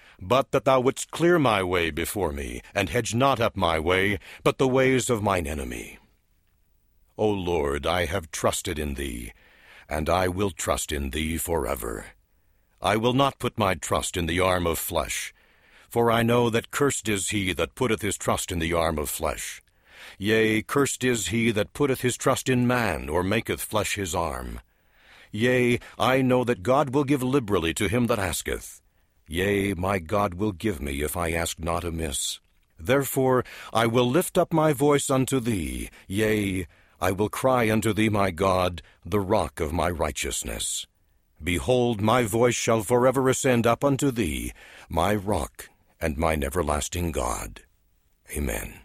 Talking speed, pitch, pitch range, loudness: 170 wpm, 100 Hz, 85-125 Hz, -25 LUFS